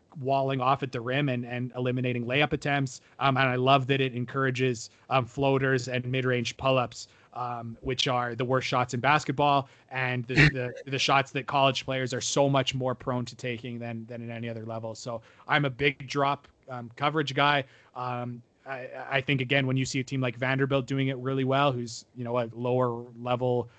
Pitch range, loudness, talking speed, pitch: 125-135 Hz, -28 LUFS, 205 wpm, 130 Hz